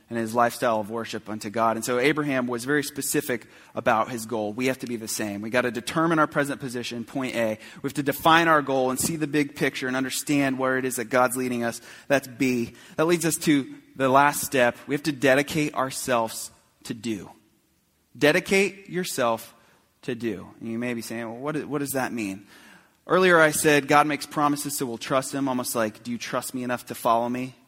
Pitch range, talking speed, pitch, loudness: 115-145 Hz, 225 wpm, 130 Hz, -24 LUFS